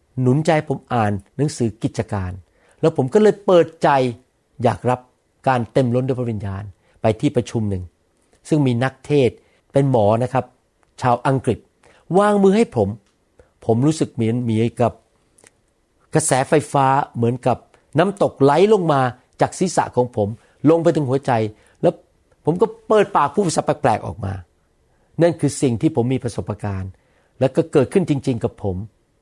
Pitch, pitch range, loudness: 125 Hz, 110-150 Hz, -19 LUFS